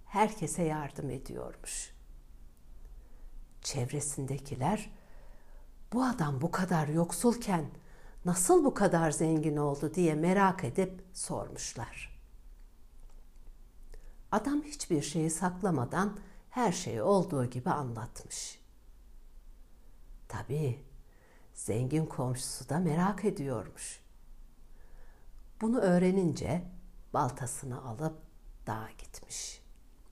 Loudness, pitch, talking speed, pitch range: -33 LUFS, 160 Hz, 80 wpm, 140-190 Hz